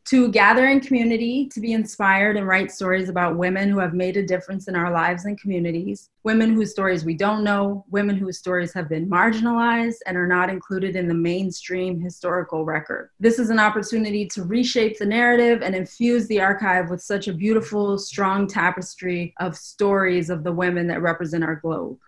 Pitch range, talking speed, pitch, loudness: 180-215 Hz, 190 wpm, 190 Hz, -21 LUFS